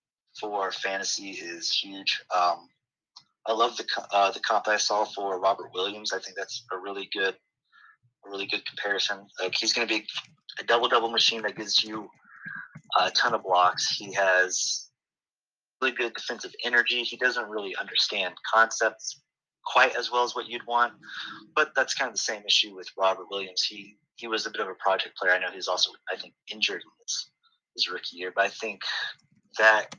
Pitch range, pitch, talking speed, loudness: 105-125 Hz, 115 Hz, 190 wpm, -26 LUFS